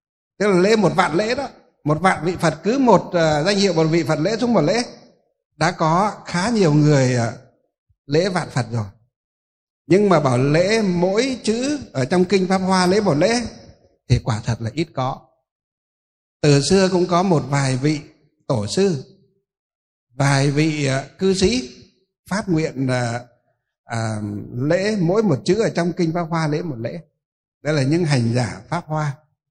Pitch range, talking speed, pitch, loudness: 130-185 Hz, 185 wpm, 155 Hz, -19 LUFS